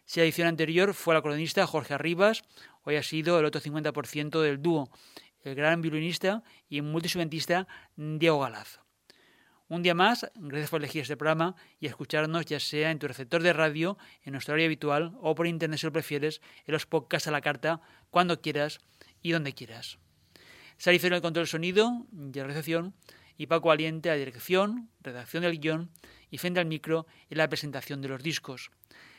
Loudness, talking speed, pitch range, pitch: -29 LUFS, 185 wpm, 150-170 Hz, 160 Hz